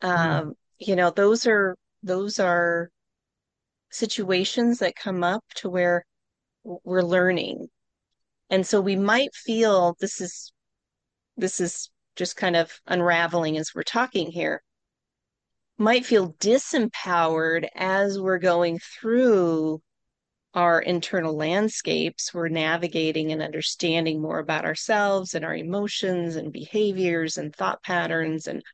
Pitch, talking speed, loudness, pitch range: 180 Hz, 120 wpm, -24 LUFS, 165-200 Hz